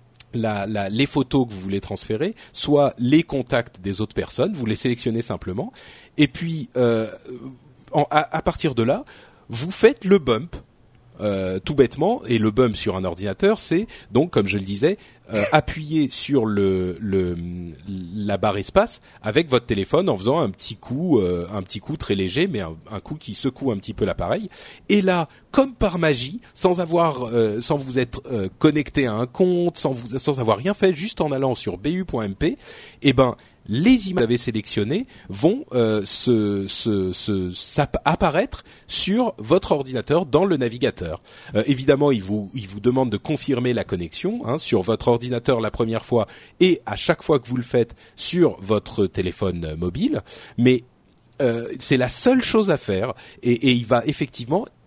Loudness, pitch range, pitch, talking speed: -22 LUFS, 105-150 Hz, 120 Hz, 185 wpm